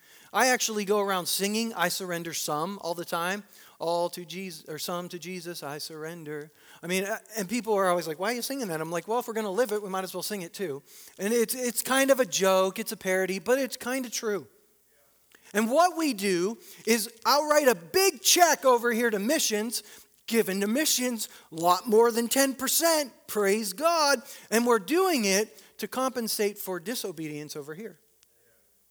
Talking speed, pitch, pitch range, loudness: 200 wpm, 215 Hz, 180-245 Hz, -27 LUFS